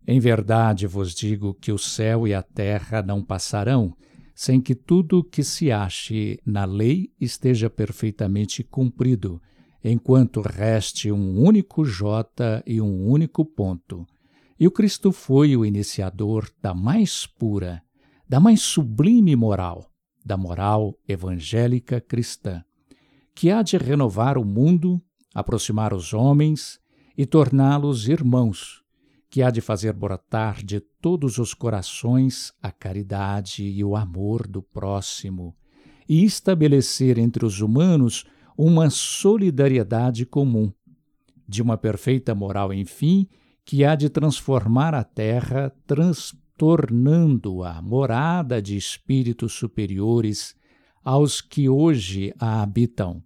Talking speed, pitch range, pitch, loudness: 120 wpm, 105-140 Hz, 120 Hz, -21 LUFS